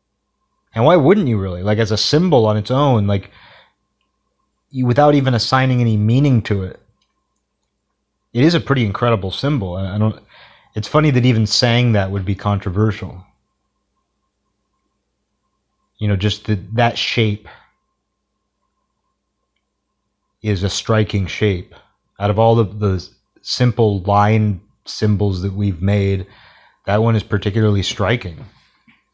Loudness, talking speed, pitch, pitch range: -16 LUFS, 135 wpm, 105 Hz, 100-120 Hz